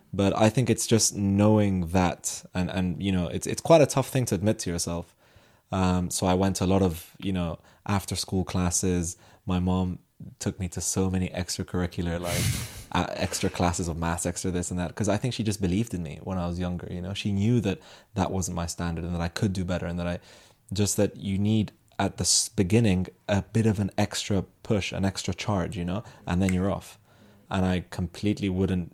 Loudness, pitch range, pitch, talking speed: -27 LUFS, 90-105 Hz, 95 Hz, 225 wpm